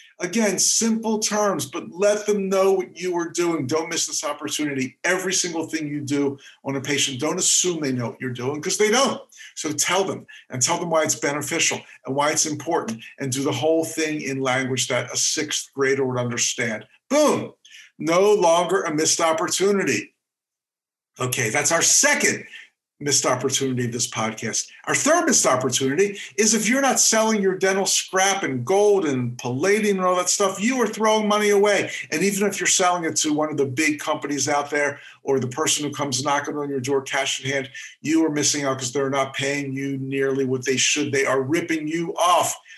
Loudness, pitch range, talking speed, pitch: -21 LUFS, 135-190 Hz, 200 wpm, 155 Hz